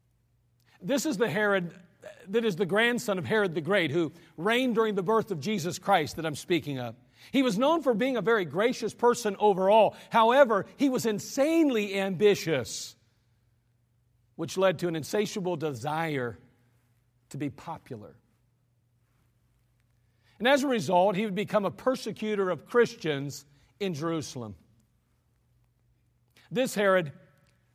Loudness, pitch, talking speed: -27 LUFS, 175 Hz, 135 wpm